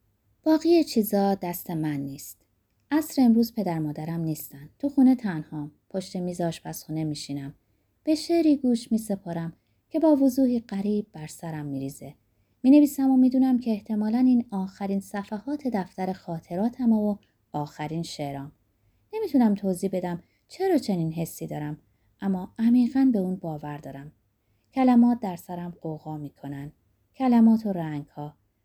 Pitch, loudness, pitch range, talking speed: 185 Hz, -25 LUFS, 150-235 Hz, 135 wpm